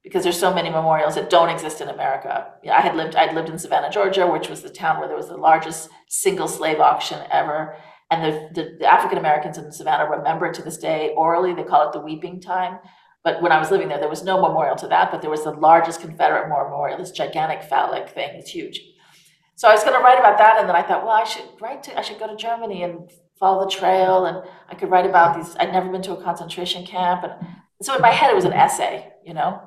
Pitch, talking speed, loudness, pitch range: 175 Hz, 255 wpm, -19 LUFS, 160-190 Hz